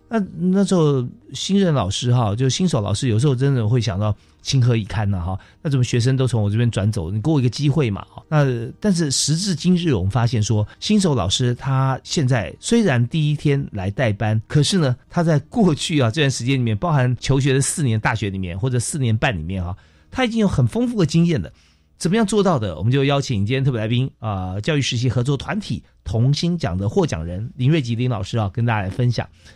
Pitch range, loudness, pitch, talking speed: 110-150 Hz, -20 LUFS, 130 Hz, 340 characters per minute